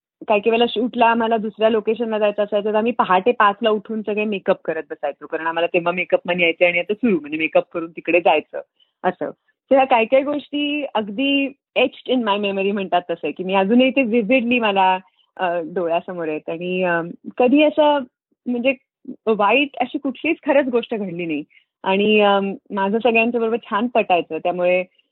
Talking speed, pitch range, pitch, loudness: 165 wpm, 180-245 Hz, 215 Hz, -19 LUFS